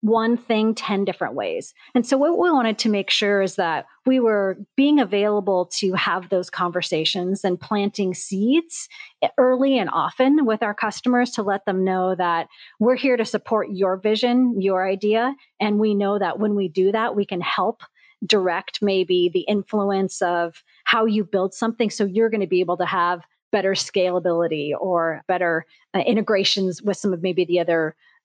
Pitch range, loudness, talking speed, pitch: 185-225 Hz, -21 LUFS, 180 wpm, 200 Hz